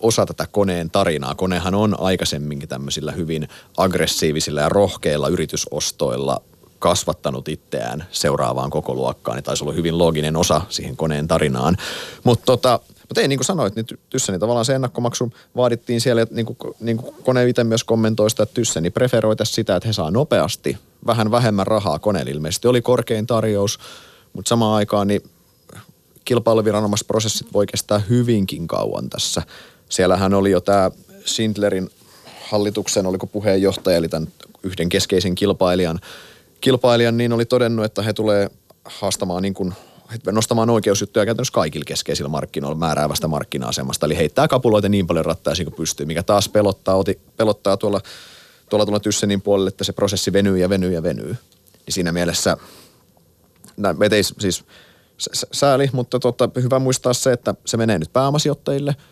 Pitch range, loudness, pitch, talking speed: 90-115 Hz, -19 LUFS, 105 Hz, 155 wpm